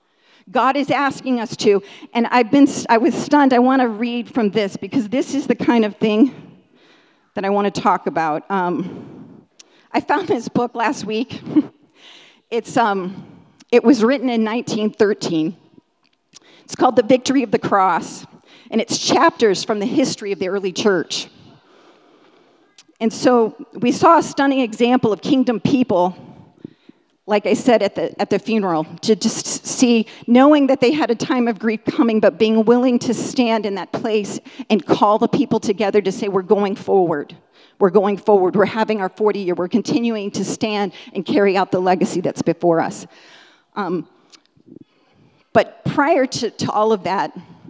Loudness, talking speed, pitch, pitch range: -18 LUFS, 170 wpm, 225 Hz, 200-265 Hz